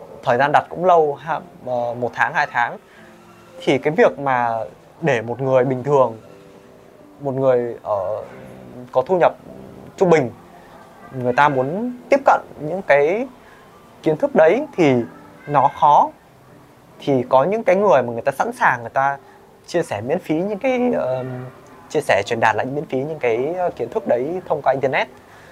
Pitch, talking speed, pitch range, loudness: 135 Hz, 175 wpm, 125-180 Hz, -19 LUFS